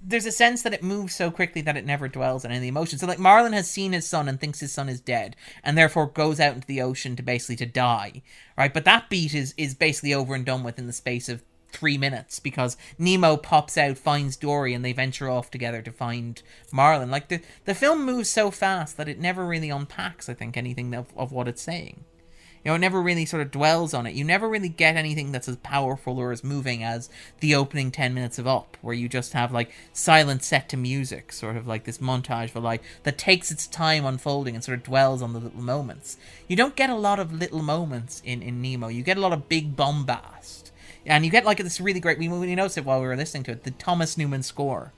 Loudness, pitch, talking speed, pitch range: -24 LUFS, 140 Hz, 250 wpm, 125-160 Hz